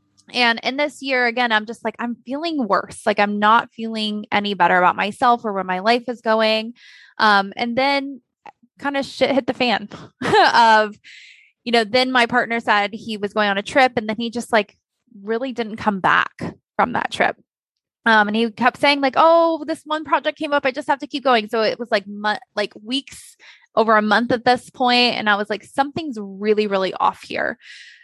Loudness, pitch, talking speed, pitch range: -19 LUFS, 235 Hz, 210 wpm, 215-260 Hz